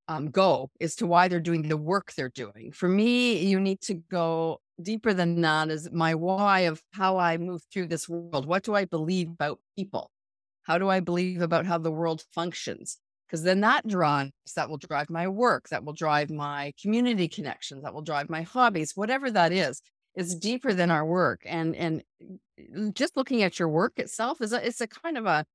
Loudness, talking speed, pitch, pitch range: -27 LUFS, 205 wpm, 175 Hz, 160-195 Hz